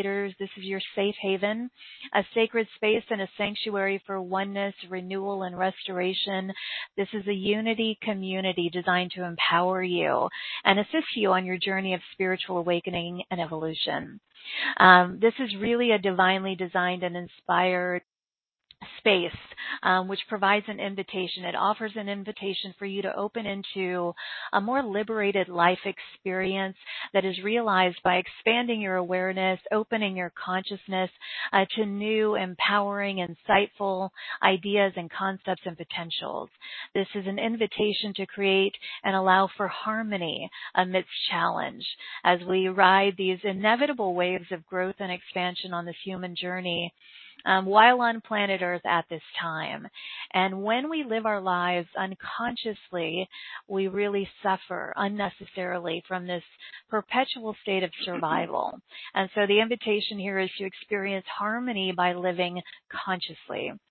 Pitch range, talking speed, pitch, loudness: 185-205 Hz, 140 wpm, 195 Hz, -27 LUFS